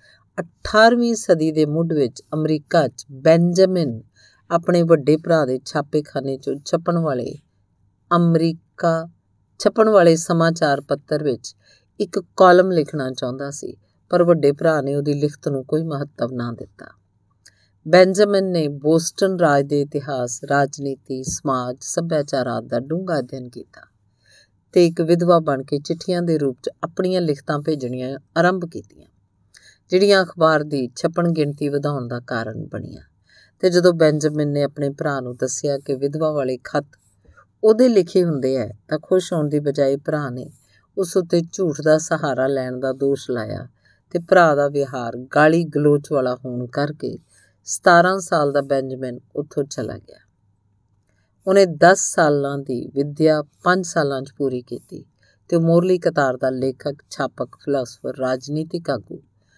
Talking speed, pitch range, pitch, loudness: 140 wpm, 130-170 Hz, 145 Hz, -19 LUFS